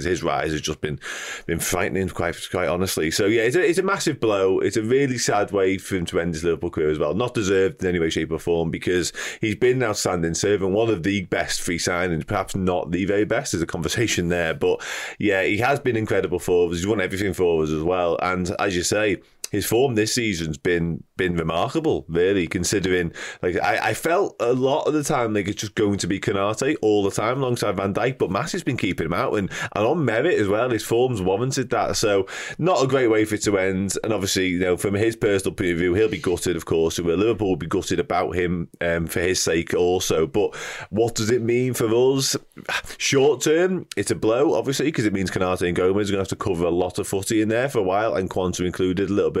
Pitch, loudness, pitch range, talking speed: 100 Hz, -22 LUFS, 90-115 Hz, 250 wpm